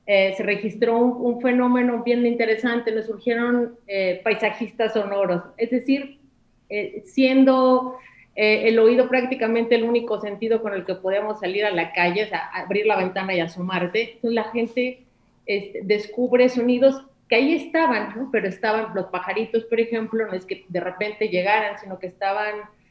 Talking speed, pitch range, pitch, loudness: 170 wpm, 200-240 Hz, 220 Hz, -22 LUFS